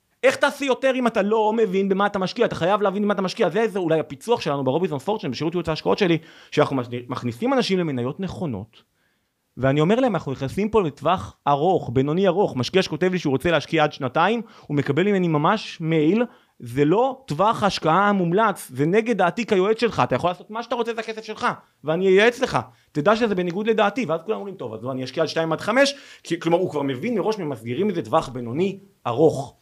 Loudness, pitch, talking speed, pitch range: -22 LUFS, 185 Hz, 180 wpm, 150-220 Hz